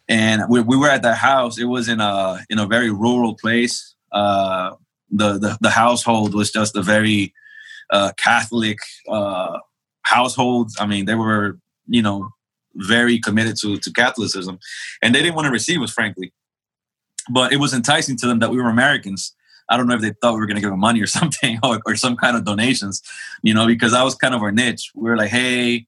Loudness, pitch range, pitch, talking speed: -17 LUFS, 105-120 Hz, 115 Hz, 210 wpm